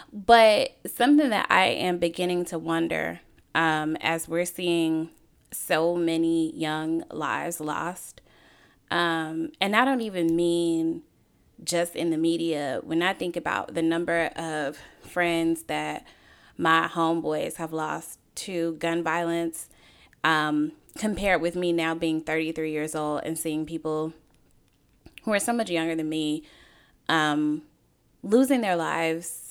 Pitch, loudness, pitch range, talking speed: 165 Hz, -26 LUFS, 155-170 Hz, 135 wpm